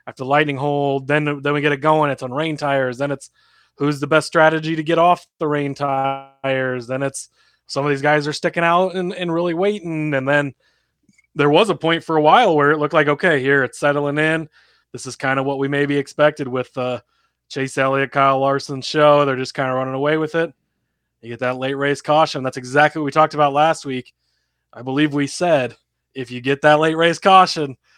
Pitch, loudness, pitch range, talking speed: 145 Hz, -18 LUFS, 135-155 Hz, 225 wpm